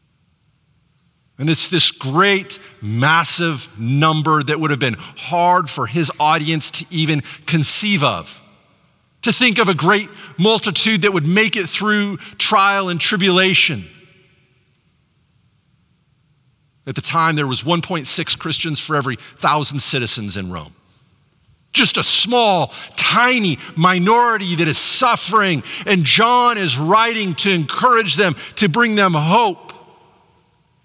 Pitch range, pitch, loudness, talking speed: 145-200 Hz, 165 Hz, -15 LUFS, 125 wpm